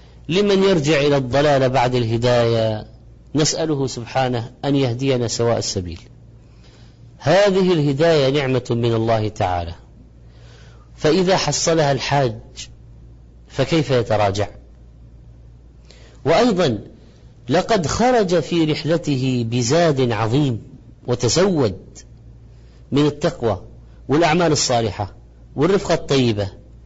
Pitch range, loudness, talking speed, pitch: 105-145 Hz, -18 LUFS, 85 wpm, 120 Hz